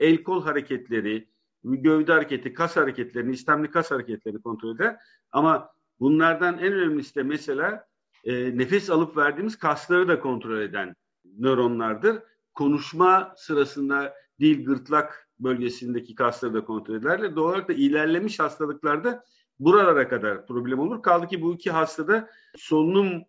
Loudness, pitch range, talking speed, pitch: -24 LUFS, 125-175 Hz, 135 wpm, 150 Hz